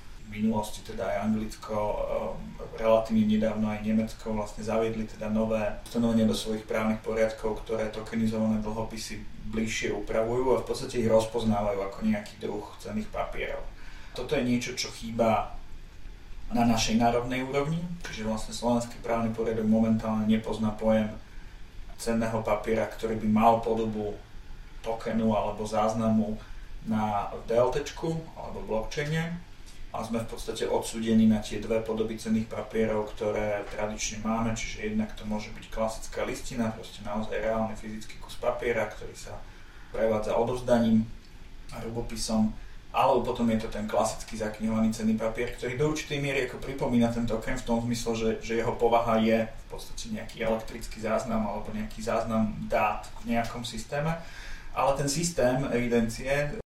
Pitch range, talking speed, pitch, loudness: 110-115 Hz, 145 wpm, 110 Hz, -29 LUFS